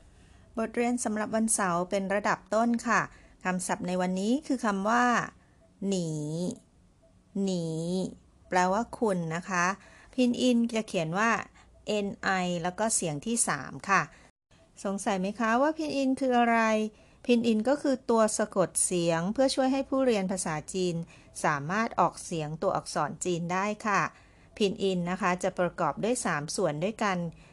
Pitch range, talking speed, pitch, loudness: 180-230 Hz, 425 characters per minute, 200 Hz, -29 LUFS